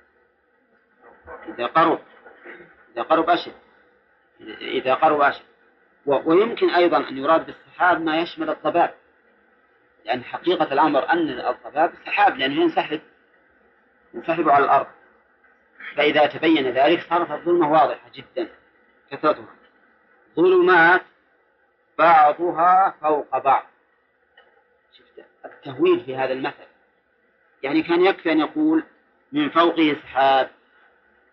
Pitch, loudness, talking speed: 175 Hz, -20 LUFS, 100 wpm